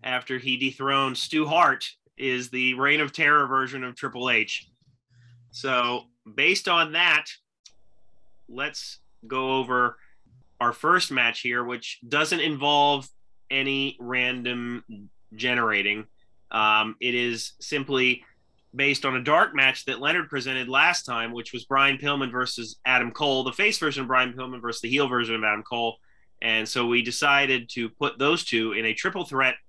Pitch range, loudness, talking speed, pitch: 120-140 Hz, -24 LUFS, 155 wpm, 130 Hz